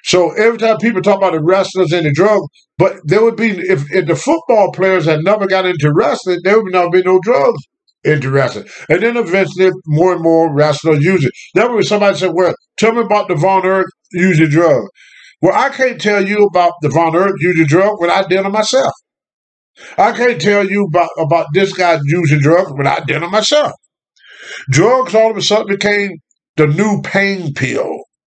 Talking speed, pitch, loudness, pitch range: 205 wpm, 190 Hz, -12 LUFS, 170-210 Hz